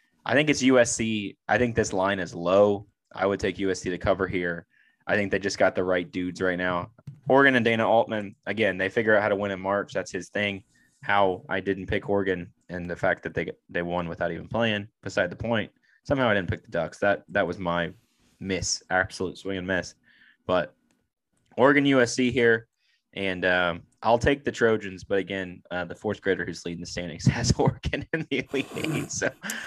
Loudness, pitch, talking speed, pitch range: -26 LUFS, 100 Hz, 205 wpm, 90-115 Hz